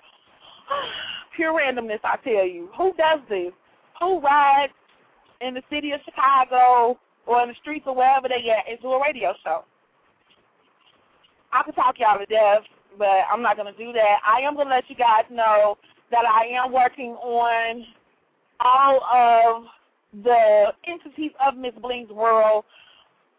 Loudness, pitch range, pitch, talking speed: -20 LUFS, 225-285 Hz, 250 Hz, 150 wpm